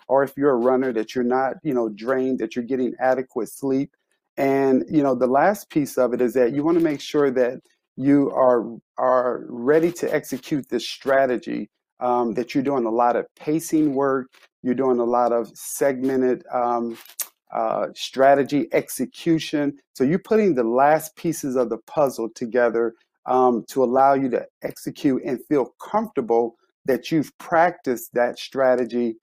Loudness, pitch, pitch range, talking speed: -22 LUFS, 130 Hz, 125-145 Hz, 170 wpm